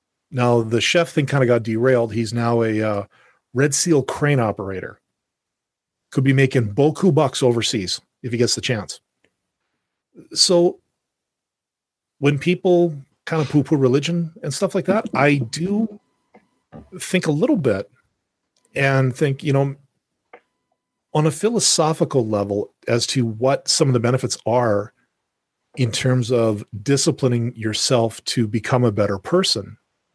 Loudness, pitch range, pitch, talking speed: -19 LUFS, 115-155 Hz, 130 Hz, 140 wpm